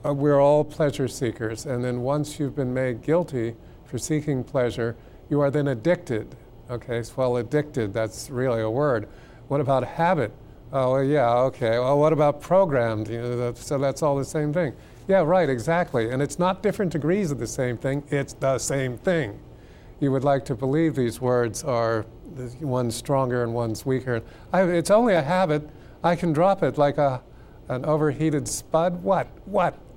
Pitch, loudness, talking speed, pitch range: 135 Hz, -24 LUFS, 195 wpm, 120-150 Hz